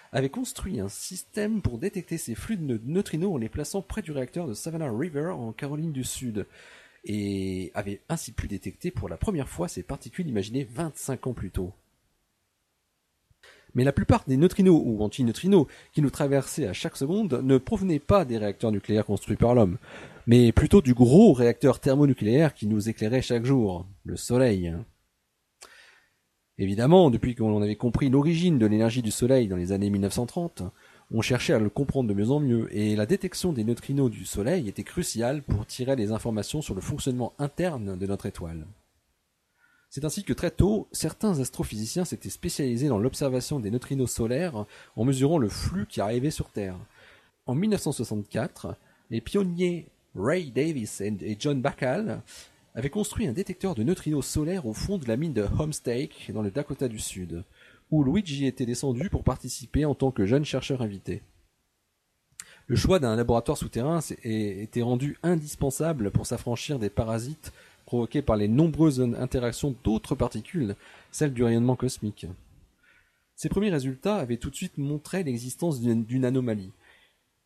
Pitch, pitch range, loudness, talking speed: 125 Hz, 110-150 Hz, -27 LUFS, 165 wpm